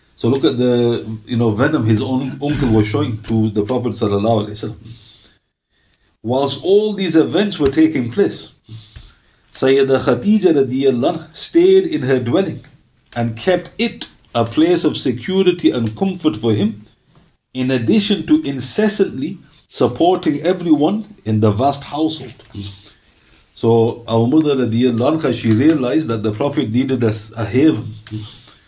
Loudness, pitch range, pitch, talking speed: -16 LUFS, 110-155 Hz, 125 Hz, 130 wpm